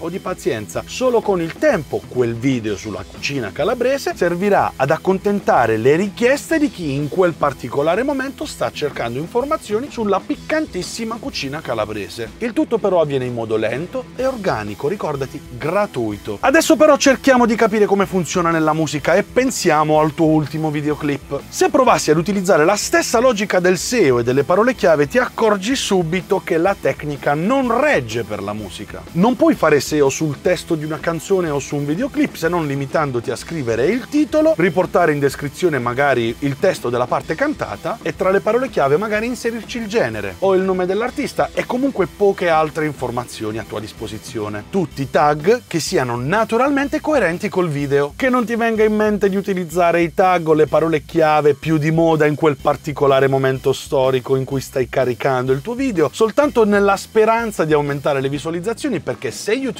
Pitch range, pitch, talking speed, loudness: 140-225 Hz, 170 Hz, 180 wpm, -17 LUFS